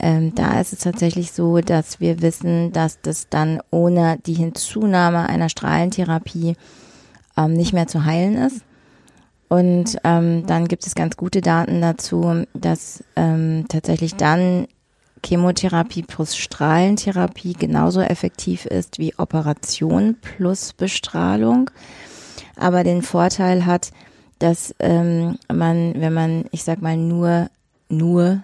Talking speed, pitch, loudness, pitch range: 125 wpm, 170 Hz, -19 LUFS, 160-175 Hz